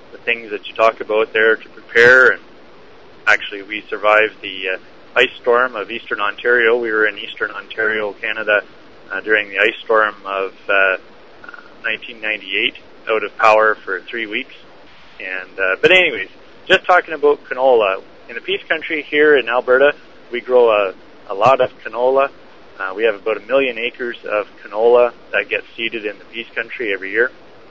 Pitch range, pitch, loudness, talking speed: 105-150 Hz, 115 Hz, -16 LUFS, 170 wpm